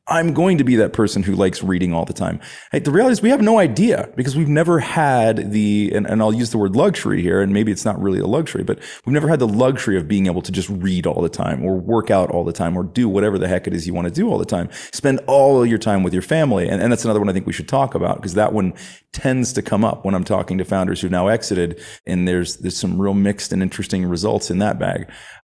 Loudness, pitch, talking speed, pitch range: -18 LUFS, 105 Hz, 280 wpm, 95-120 Hz